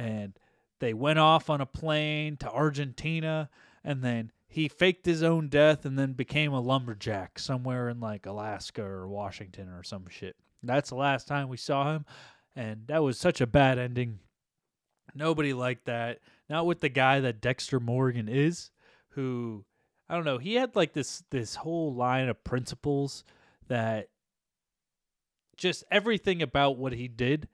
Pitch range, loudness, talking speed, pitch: 120-155 Hz, -29 LUFS, 165 wpm, 135 Hz